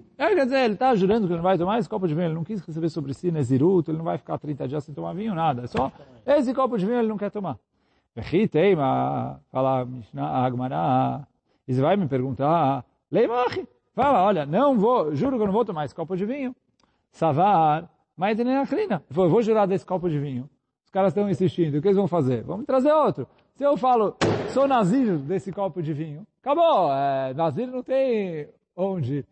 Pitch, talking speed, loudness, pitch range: 180 Hz, 205 wpm, -23 LUFS, 145-220 Hz